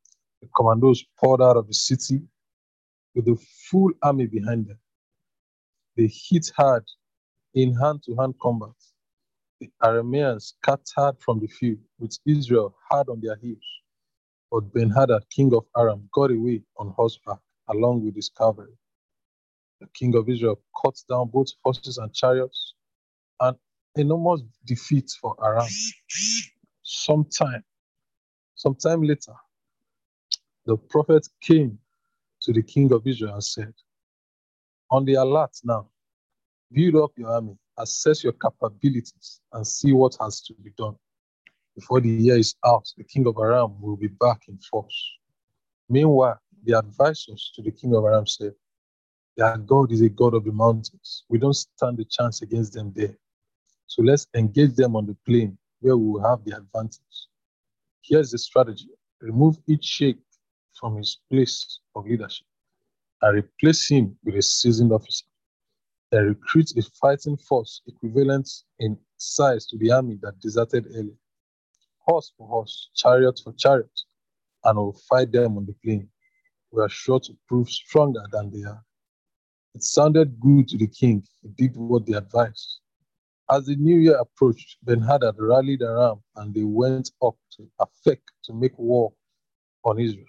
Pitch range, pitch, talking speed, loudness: 110-135 Hz, 120 Hz, 150 wpm, -22 LUFS